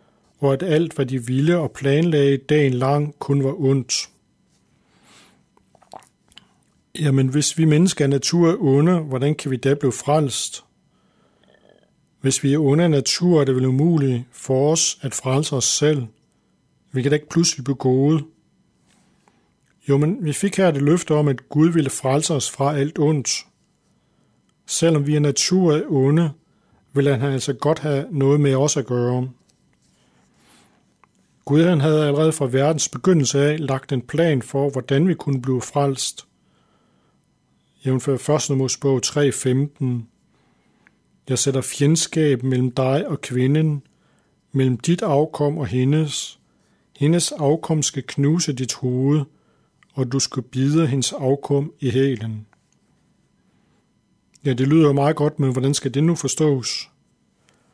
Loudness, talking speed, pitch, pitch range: -19 LUFS, 145 wpm, 140 Hz, 135-155 Hz